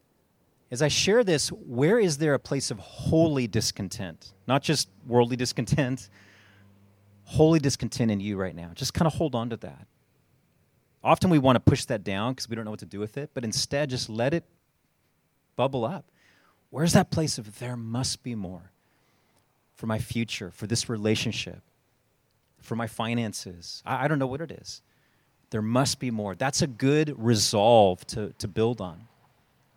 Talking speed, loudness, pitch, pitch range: 175 wpm, -26 LUFS, 120 Hz, 105-135 Hz